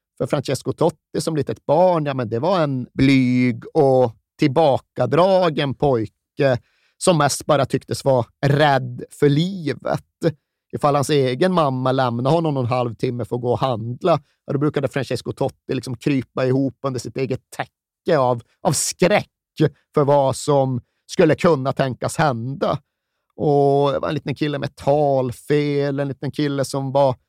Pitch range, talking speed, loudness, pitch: 125-145 Hz, 155 wpm, -20 LUFS, 135 Hz